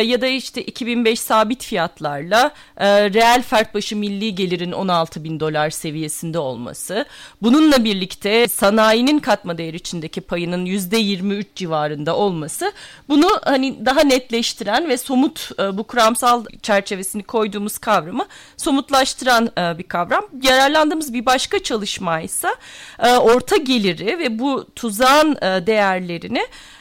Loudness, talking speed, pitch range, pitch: -18 LUFS, 125 wpm, 185-255 Hz, 220 Hz